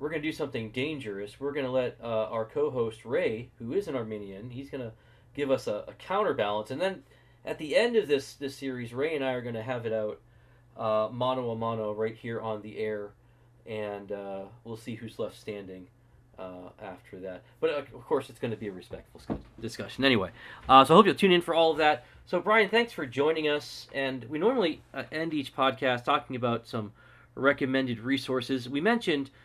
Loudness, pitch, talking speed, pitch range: -29 LUFS, 125 Hz, 210 wpm, 110-140 Hz